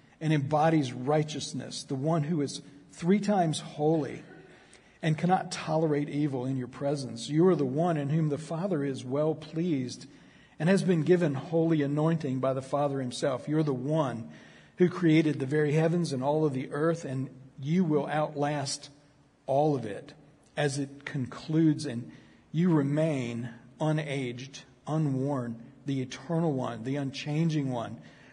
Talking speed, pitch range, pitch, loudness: 155 wpm, 135-160 Hz, 145 Hz, -29 LUFS